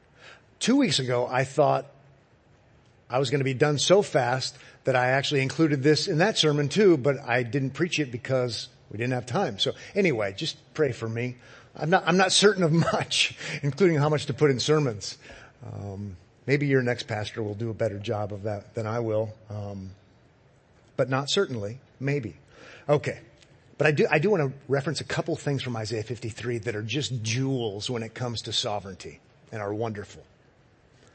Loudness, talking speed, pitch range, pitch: -26 LUFS, 190 wpm, 115-150 Hz, 125 Hz